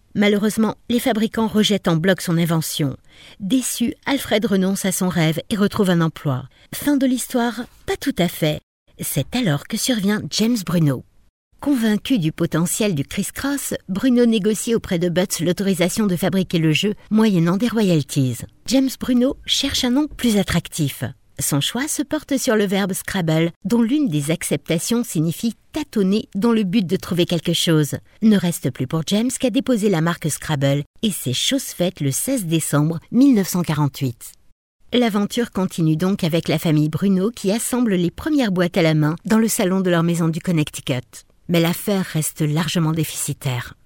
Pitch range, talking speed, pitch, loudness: 160-225 Hz, 170 wpm, 185 Hz, -20 LUFS